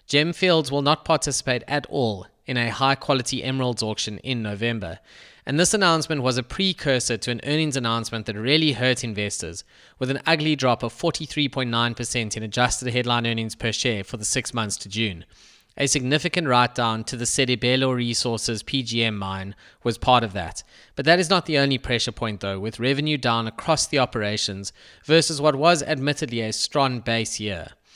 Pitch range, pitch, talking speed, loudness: 115-145 Hz, 125 Hz, 180 wpm, -22 LUFS